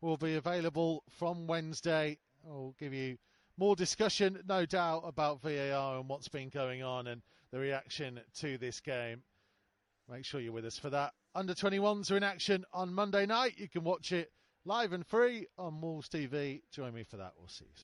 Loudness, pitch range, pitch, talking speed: -36 LUFS, 130-180 Hz, 150 Hz, 195 wpm